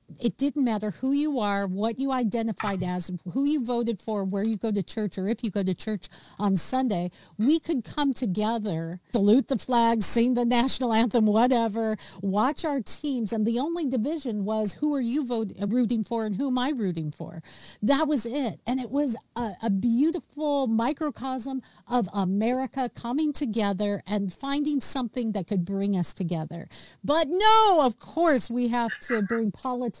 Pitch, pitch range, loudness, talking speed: 230 Hz, 205-265 Hz, -26 LUFS, 180 wpm